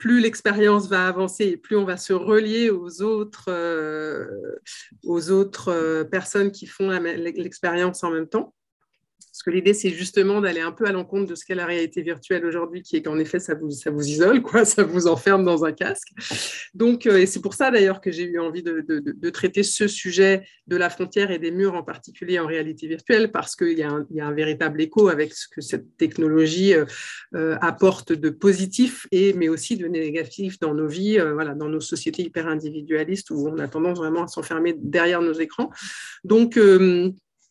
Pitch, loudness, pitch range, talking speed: 180 Hz, -22 LUFS, 165-200 Hz, 205 wpm